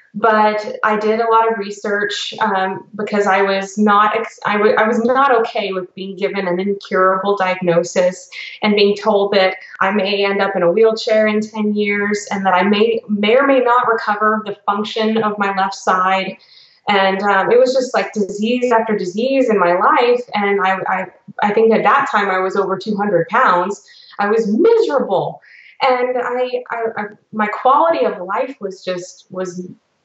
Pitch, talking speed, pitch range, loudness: 210 Hz, 185 wpm, 195-225 Hz, -16 LUFS